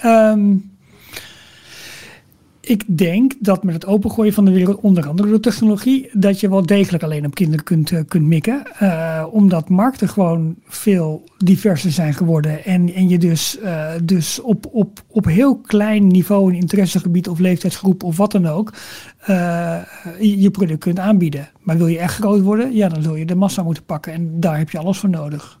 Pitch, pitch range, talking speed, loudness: 185 Hz, 170-205 Hz, 185 wpm, -16 LUFS